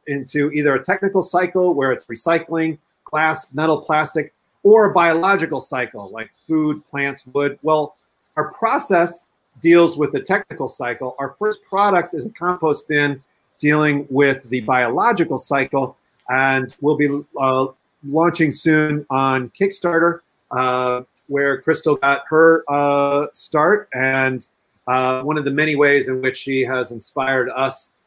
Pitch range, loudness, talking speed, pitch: 135-165 Hz, -18 LUFS, 145 wpm, 145 Hz